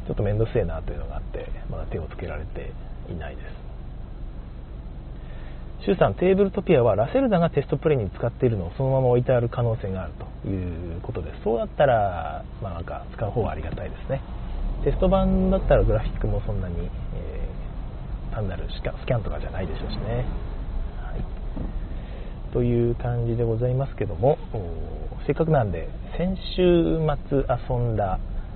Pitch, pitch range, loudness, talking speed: 110 Hz, 85-135 Hz, -25 LUFS, 370 characters per minute